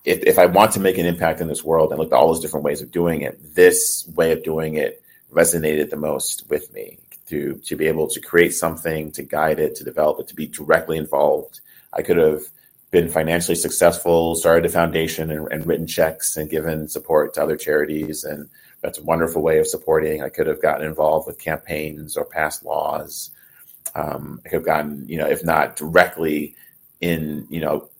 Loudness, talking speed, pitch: -20 LUFS, 210 wpm, 85 Hz